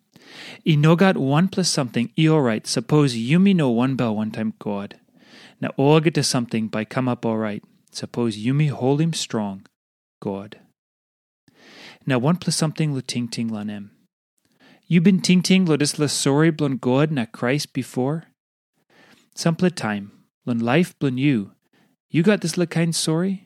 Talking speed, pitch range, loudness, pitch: 175 wpm, 115-165 Hz, -21 LUFS, 140 Hz